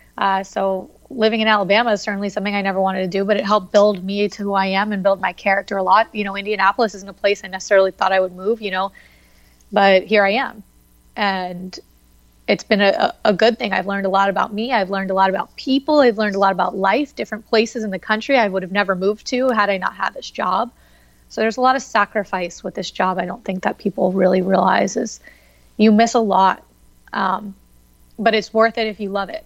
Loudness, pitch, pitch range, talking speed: -18 LUFS, 200 Hz, 190-215 Hz, 240 wpm